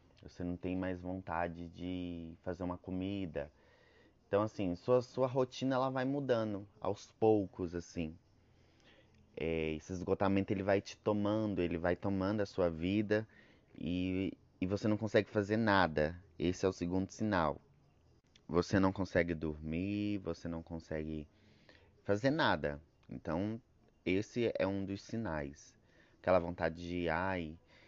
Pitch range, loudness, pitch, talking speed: 85-105 Hz, -36 LUFS, 95 Hz, 140 wpm